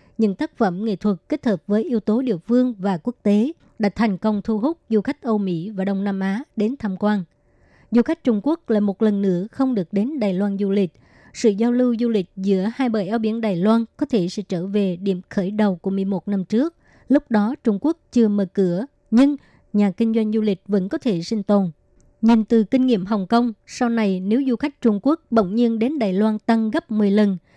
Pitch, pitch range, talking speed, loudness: 215 Hz, 200-235 Hz, 240 wpm, -21 LUFS